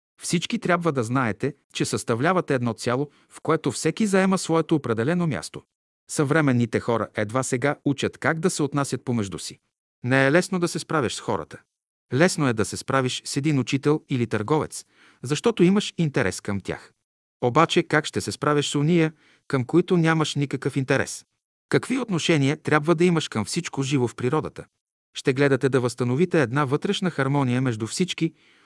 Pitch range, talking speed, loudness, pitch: 125-165 Hz, 165 wpm, -23 LUFS, 145 Hz